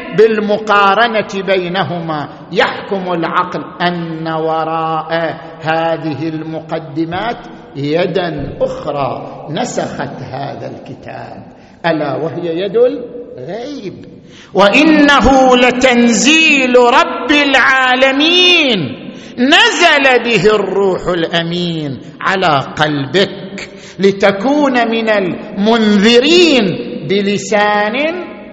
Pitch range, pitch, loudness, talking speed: 165-250 Hz, 200 Hz, -12 LUFS, 65 wpm